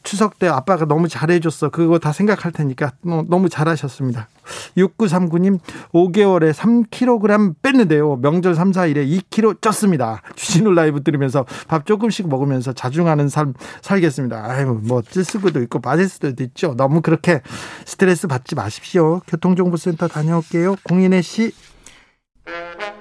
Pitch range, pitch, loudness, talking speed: 145-185 Hz, 170 Hz, -17 LUFS, 315 characters per minute